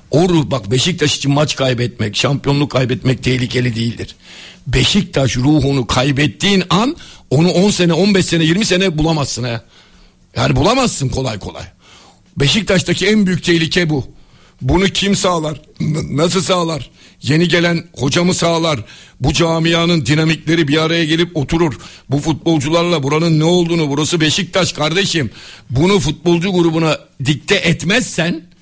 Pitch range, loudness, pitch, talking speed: 135-175 Hz, -14 LUFS, 160 Hz, 130 wpm